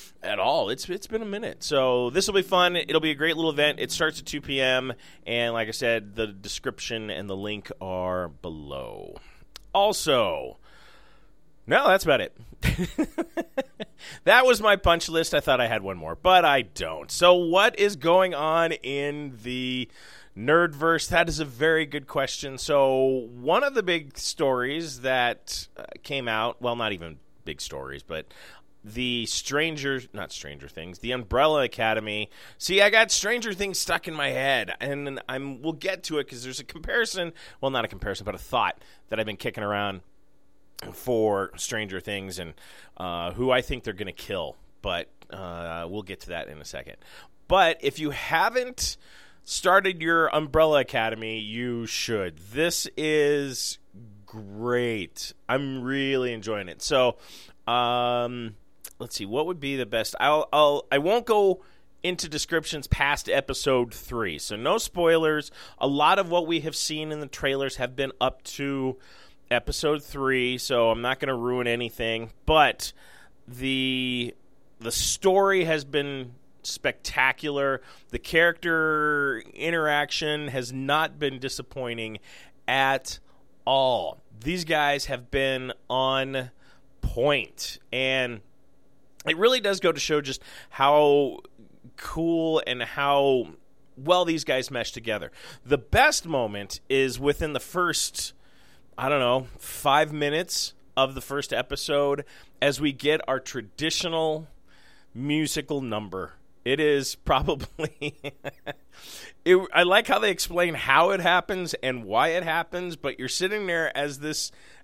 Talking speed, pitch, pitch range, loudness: 150 wpm, 135 Hz, 120-160 Hz, -25 LUFS